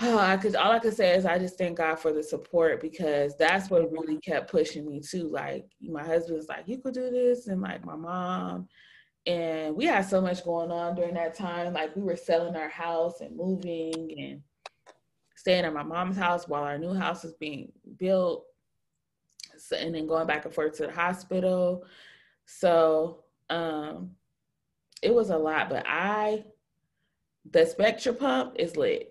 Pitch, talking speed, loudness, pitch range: 175 Hz, 185 wpm, -28 LUFS, 160-190 Hz